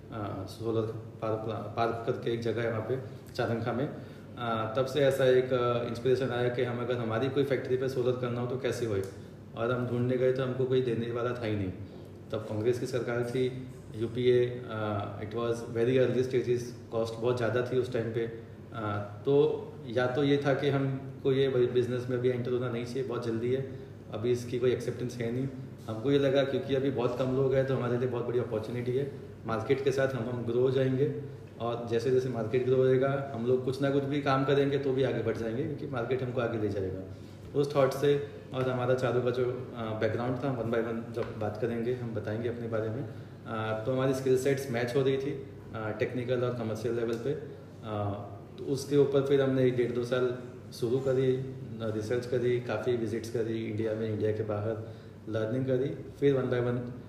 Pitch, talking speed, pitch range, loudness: 125 Hz, 205 wpm, 115-130 Hz, -31 LUFS